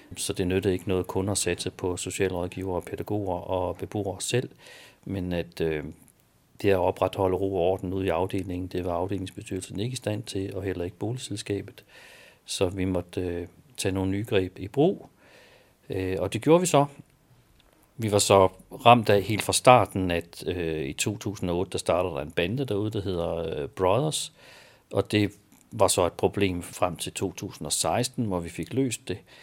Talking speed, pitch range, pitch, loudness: 175 wpm, 90-105 Hz, 95 Hz, -27 LUFS